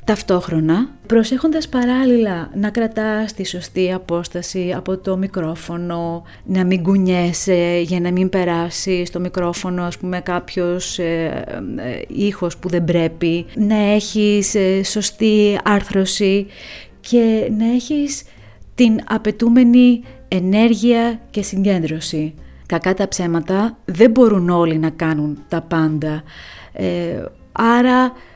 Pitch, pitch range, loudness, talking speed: 190 Hz, 175-220 Hz, -17 LUFS, 115 wpm